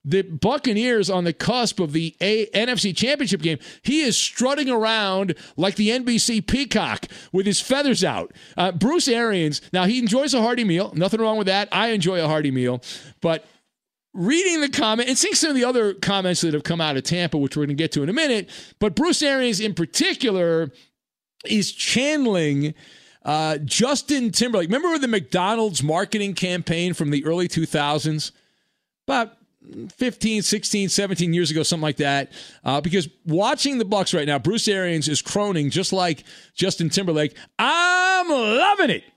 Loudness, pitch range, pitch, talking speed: -21 LUFS, 165-235 Hz, 195 Hz, 175 wpm